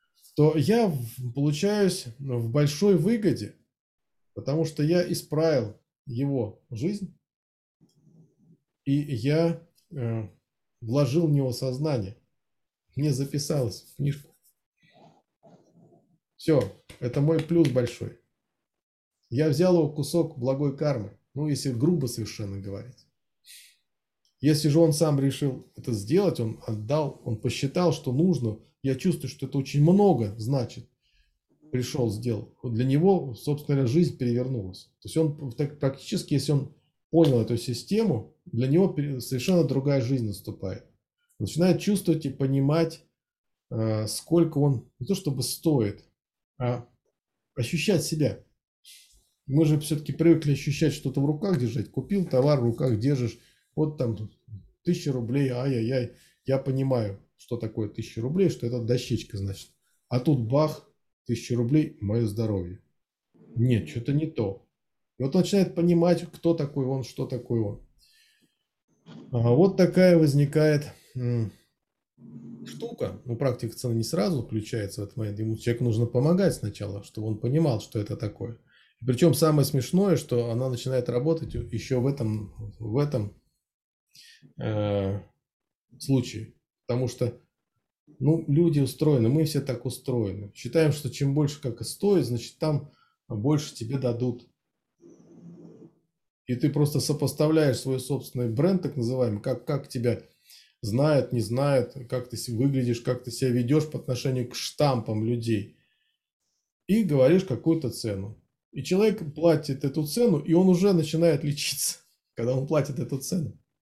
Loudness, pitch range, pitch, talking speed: -26 LUFS, 120-155 Hz, 135 Hz, 135 wpm